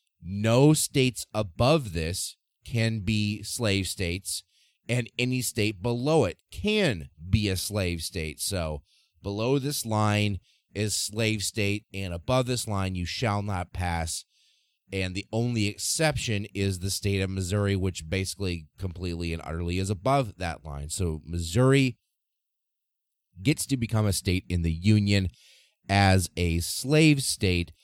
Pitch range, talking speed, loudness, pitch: 90-115 Hz, 140 wpm, -27 LUFS, 100 Hz